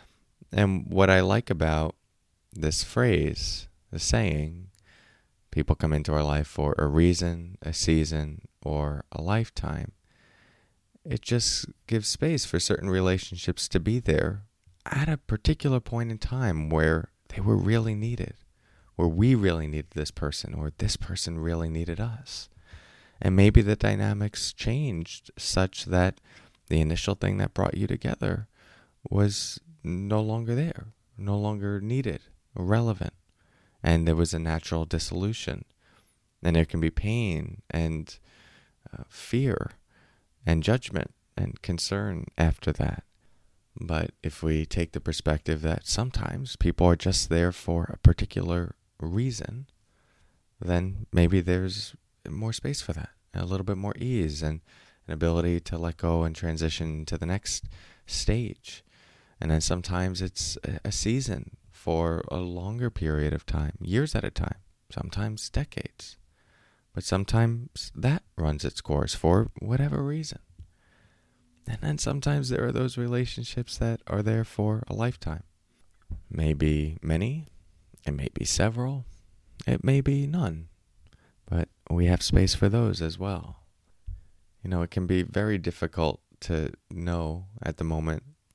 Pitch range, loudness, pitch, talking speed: 80-110 Hz, -28 LUFS, 95 Hz, 140 wpm